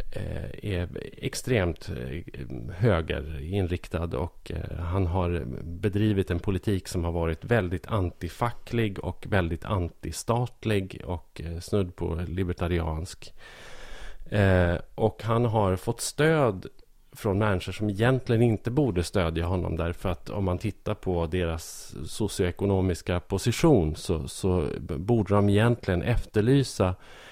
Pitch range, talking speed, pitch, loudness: 85-110 Hz, 110 wpm, 95 Hz, -27 LUFS